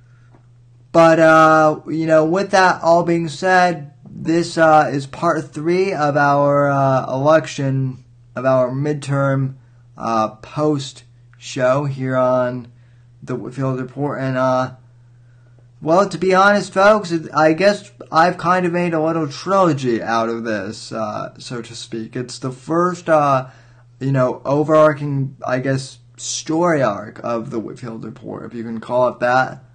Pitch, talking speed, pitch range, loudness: 135 Hz, 150 wpm, 120-160 Hz, -17 LUFS